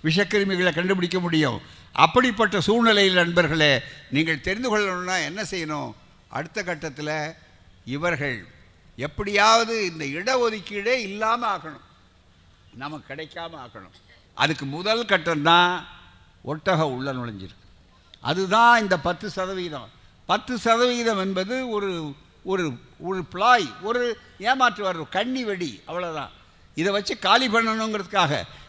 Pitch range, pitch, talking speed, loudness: 140-210 Hz, 175 Hz, 100 wpm, -22 LUFS